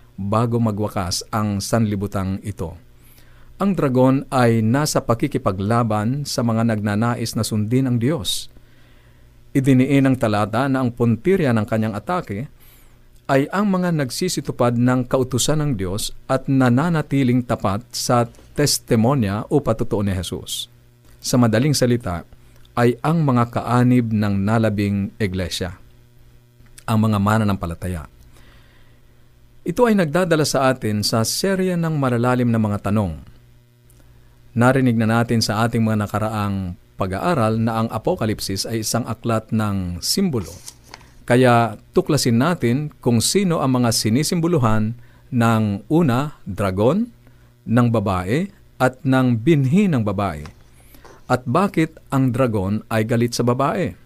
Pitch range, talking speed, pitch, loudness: 110-130 Hz, 125 wpm, 120 Hz, -19 LUFS